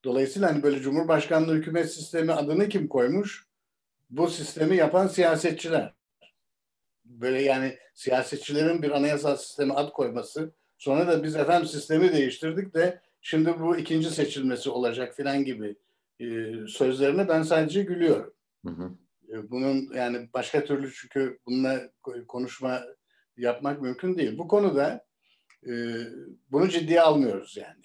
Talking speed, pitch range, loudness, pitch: 120 wpm, 130-165 Hz, -26 LUFS, 145 Hz